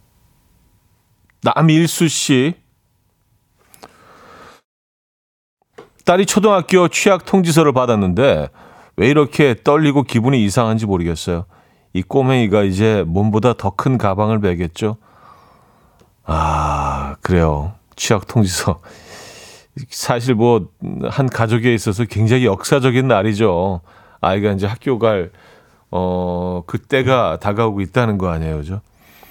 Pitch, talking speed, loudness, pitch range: 110 Hz, 230 characters per minute, -16 LUFS, 95-130 Hz